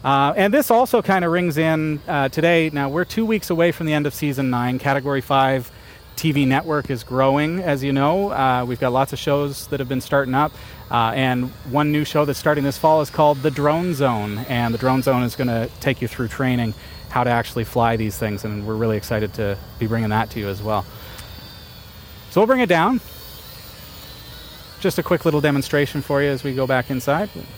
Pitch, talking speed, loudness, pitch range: 135 Hz, 220 wpm, -20 LUFS, 115-150 Hz